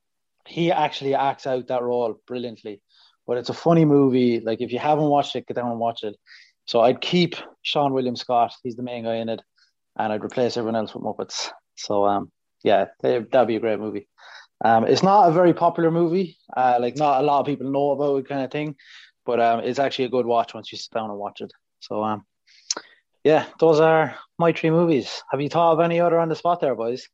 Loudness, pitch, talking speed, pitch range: -22 LUFS, 130 Hz, 230 wpm, 115-155 Hz